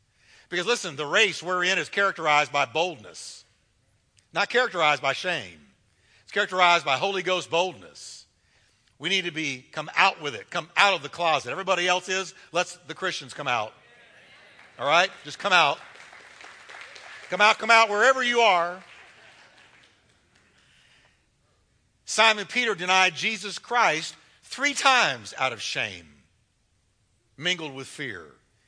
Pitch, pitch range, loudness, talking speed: 175 Hz, 135-195 Hz, -23 LUFS, 140 wpm